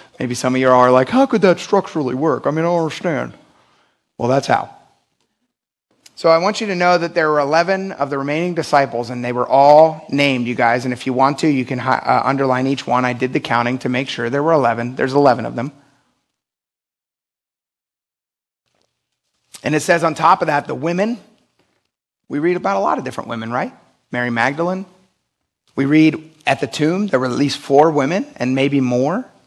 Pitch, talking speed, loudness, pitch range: 140 Hz, 205 wpm, -17 LUFS, 125-170 Hz